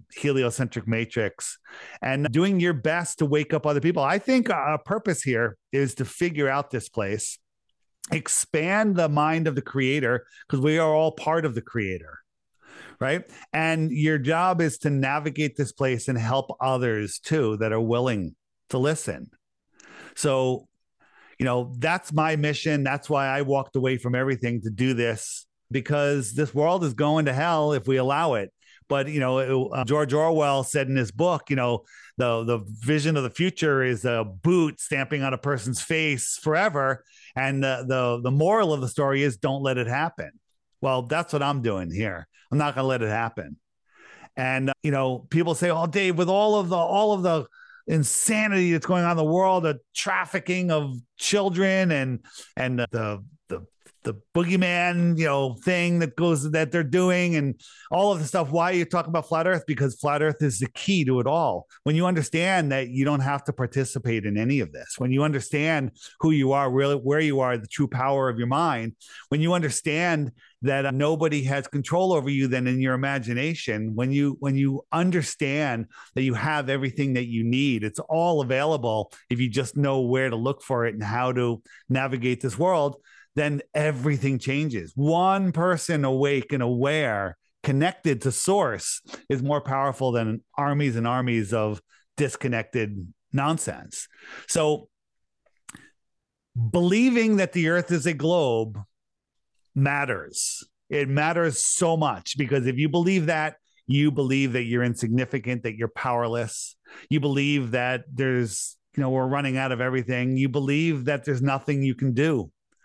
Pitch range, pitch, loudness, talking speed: 125-160 Hz, 140 Hz, -24 LUFS, 180 wpm